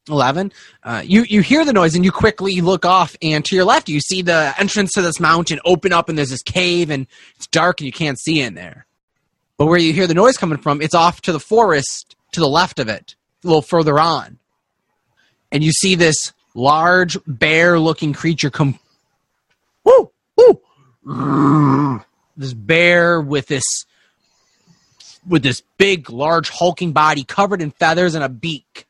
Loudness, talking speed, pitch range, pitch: -15 LUFS, 180 wpm, 145-185 Hz, 165 Hz